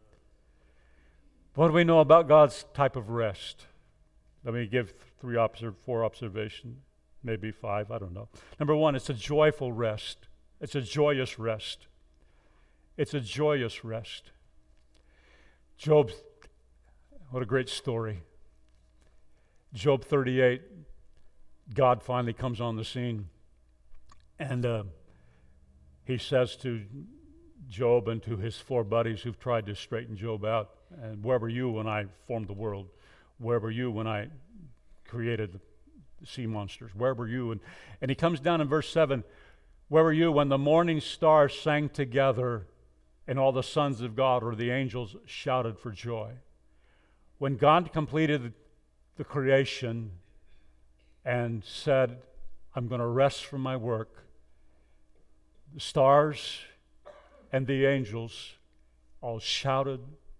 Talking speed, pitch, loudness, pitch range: 135 wpm, 120 Hz, -29 LUFS, 100-135 Hz